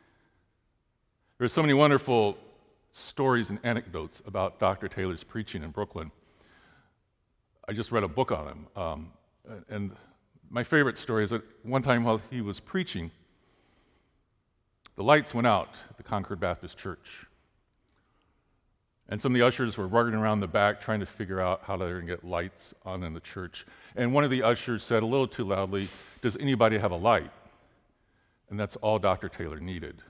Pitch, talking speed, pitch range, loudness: 105 Hz, 170 wpm, 95-120 Hz, -28 LUFS